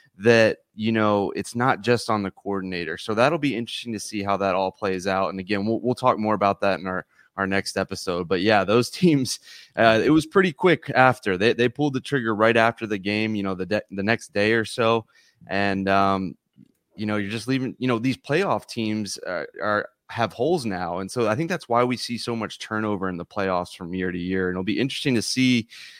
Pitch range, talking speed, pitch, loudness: 100-120 Hz, 235 wpm, 110 Hz, -23 LUFS